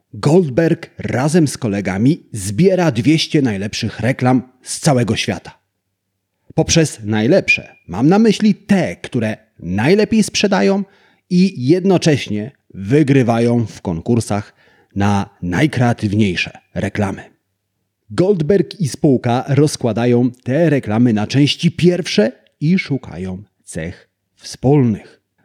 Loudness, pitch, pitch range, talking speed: -16 LUFS, 125 Hz, 105-165 Hz, 95 wpm